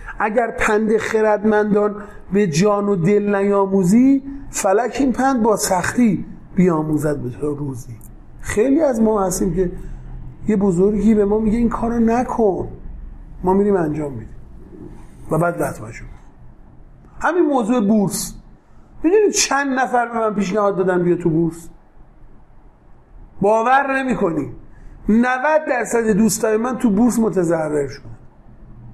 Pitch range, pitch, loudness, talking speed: 175-235 Hz, 205 Hz, -18 LUFS, 125 wpm